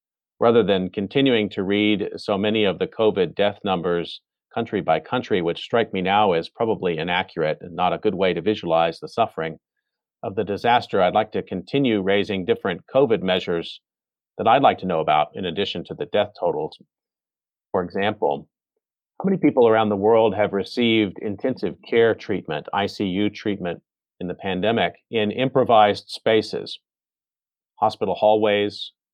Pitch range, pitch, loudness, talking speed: 100-115 Hz, 105 Hz, -22 LUFS, 160 wpm